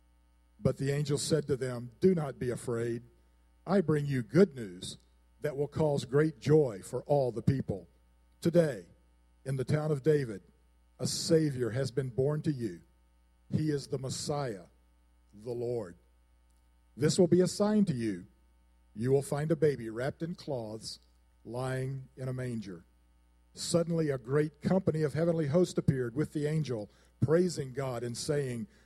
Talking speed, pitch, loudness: 160 wpm, 130 Hz, -32 LUFS